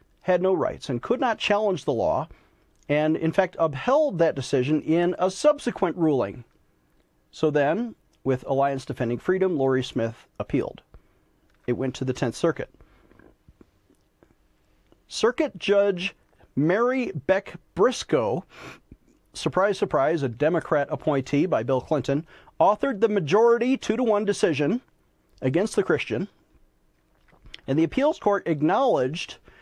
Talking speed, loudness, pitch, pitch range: 125 wpm, -24 LUFS, 160 Hz, 135-205 Hz